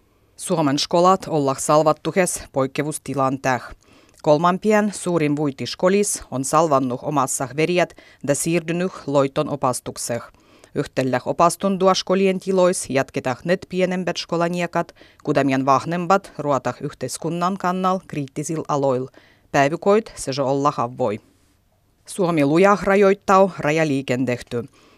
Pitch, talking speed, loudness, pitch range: 150 Hz, 100 wpm, -20 LUFS, 135-180 Hz